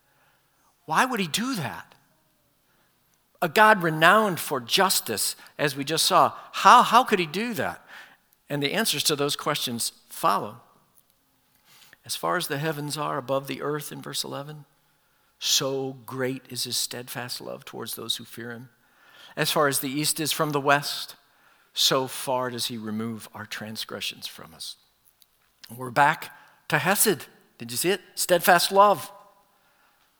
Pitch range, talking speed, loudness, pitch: 130-180 Hz, 155 wpm, -24 LUFS, 145 Hz